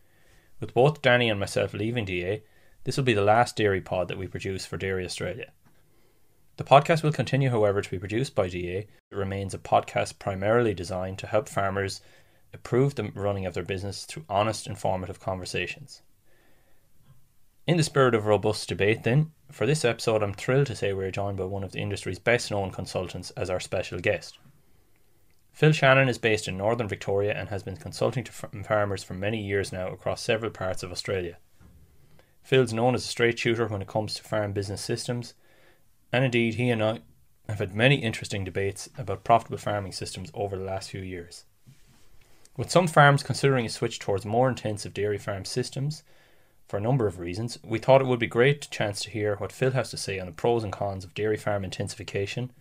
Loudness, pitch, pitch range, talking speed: -27 LUFS, 105 Hz, 95-125 Hz, 195 wpm